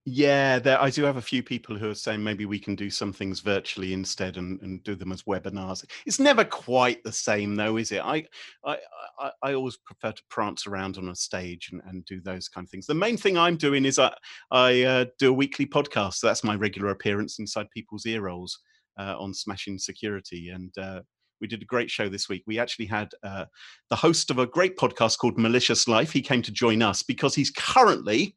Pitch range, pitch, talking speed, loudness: 95-130 Hz, 105 Hz, 225 wpm, -25 LUFS